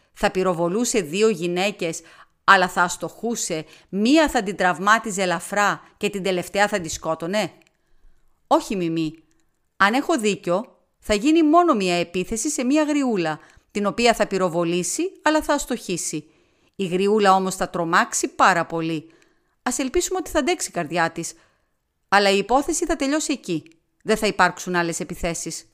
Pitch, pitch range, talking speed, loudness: 195 Hz, 170-235 Hz, 150 wpm, -21 LUFS